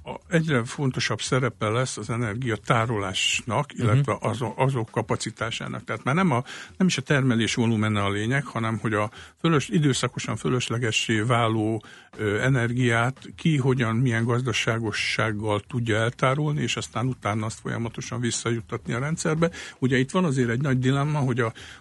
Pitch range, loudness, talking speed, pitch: 110-130 Hz, -25 LUFS, 145 wpm, 120 Hz